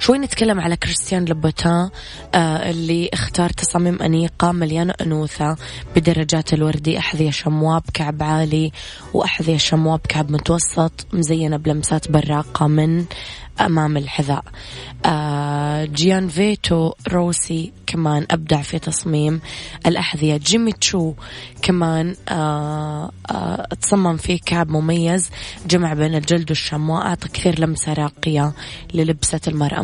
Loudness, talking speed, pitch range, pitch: -19 LUFS, 115 wpm, 150-170 Hz, 160 Hz